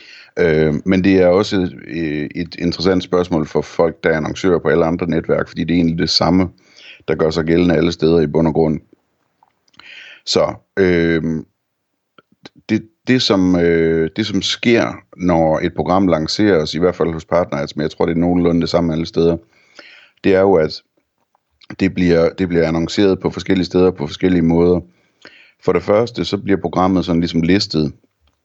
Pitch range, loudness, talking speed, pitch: 80-95 Hz, -16 LUFS, 180 wpm, 85 Hz